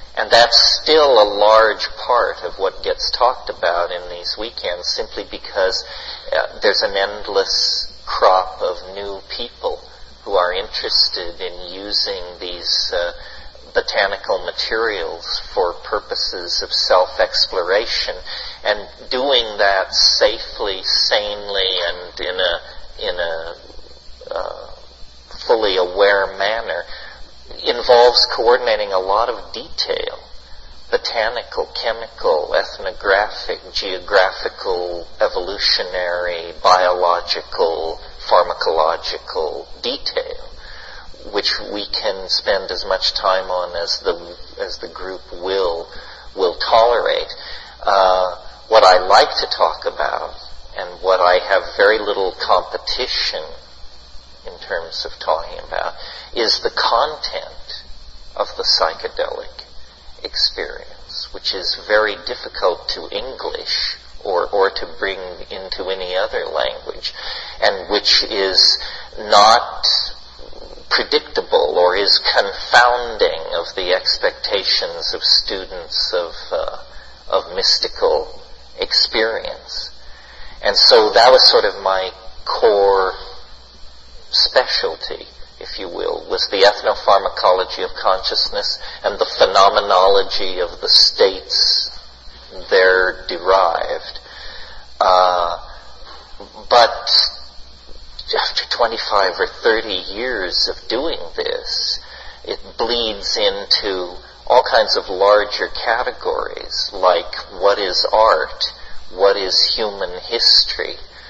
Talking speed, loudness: 100 wpm, -16 LUFS